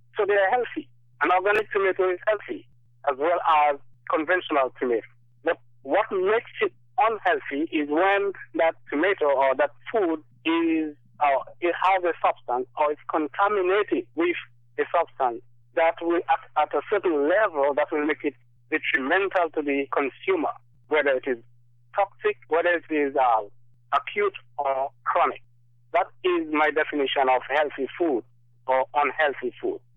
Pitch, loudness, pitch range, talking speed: 155 Hz, -25 LUFS, 130-195 Hz, 145 wpm